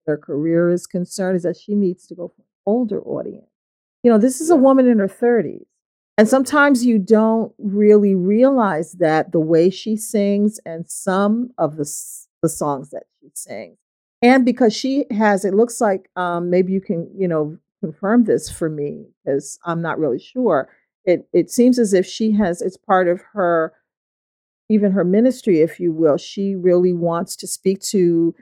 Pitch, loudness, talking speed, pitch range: 195 Hz, -18 LUFS, 185 wpm, 170-220 Hz